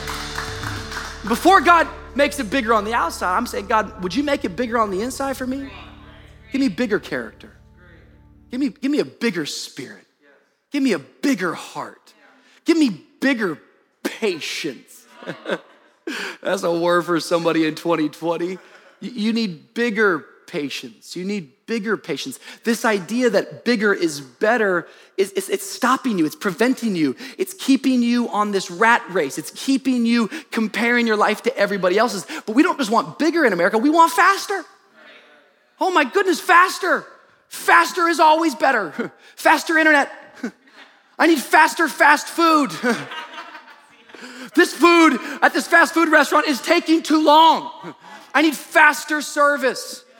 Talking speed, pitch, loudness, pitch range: 150 wpm, 260 Hz, -19 LUFS, 210-315 Hz